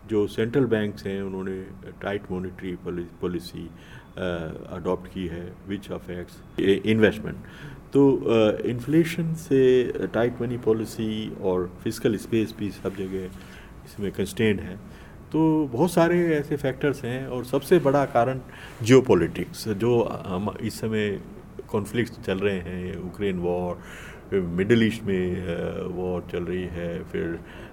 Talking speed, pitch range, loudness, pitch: 130 wpm, 90-120 Hz, -25 LUFS, 105 Hz